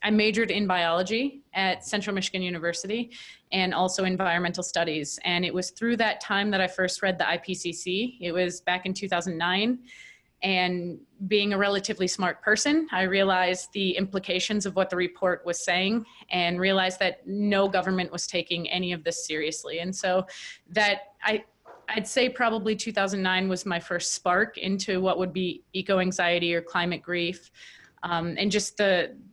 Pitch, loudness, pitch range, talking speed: 185 Hz, -26 LUFS, 175-205 Hz, 165 wpm